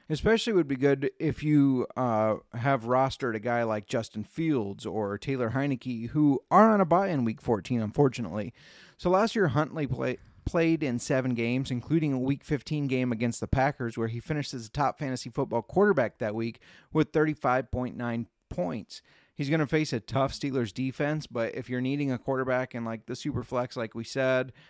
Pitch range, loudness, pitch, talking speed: 120-150 Hz, -28 LUFS, 130 Hz, 195 wpm